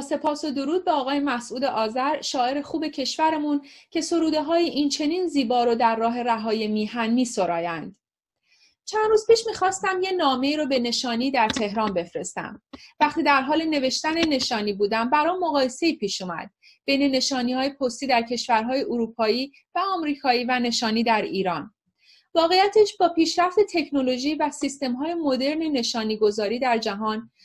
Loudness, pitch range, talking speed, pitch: -23 LUFS, 230-315 Hz, 155 wpm, 270 Hz